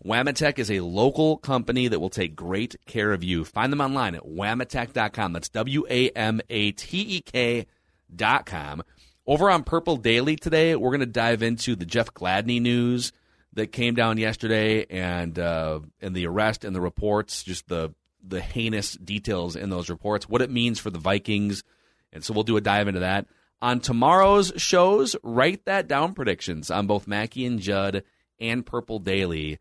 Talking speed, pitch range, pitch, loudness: 170 wpm, 95-125 Hz, 110 Hz, -24 LUFS